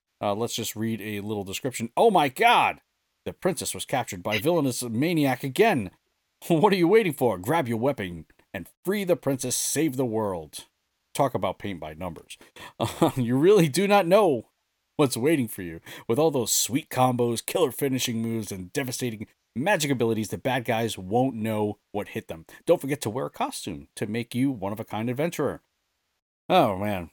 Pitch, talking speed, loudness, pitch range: 120 Hz, 185 wpm, -25 LUFS, 105-140 Hz